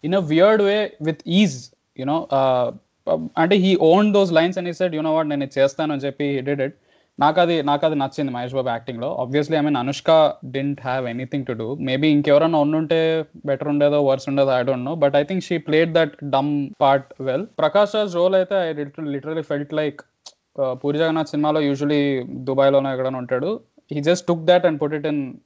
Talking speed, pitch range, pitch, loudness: 200 wpm, 135-160 Hz, 145 Hz, -20 LUFS